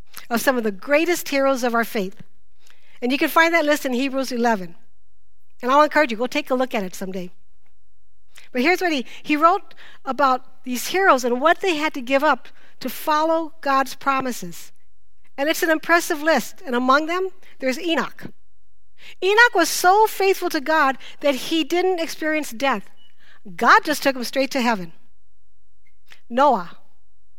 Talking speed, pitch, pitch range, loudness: 170 wpm, 265 Hz, 190-315 Hz, -20 LUFS